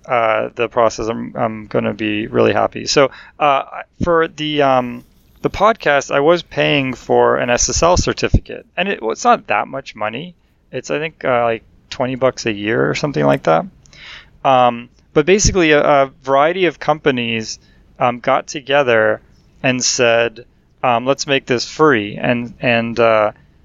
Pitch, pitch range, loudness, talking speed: 125 Hz, 115-145 Hz, -16 LUFS, 165 wpm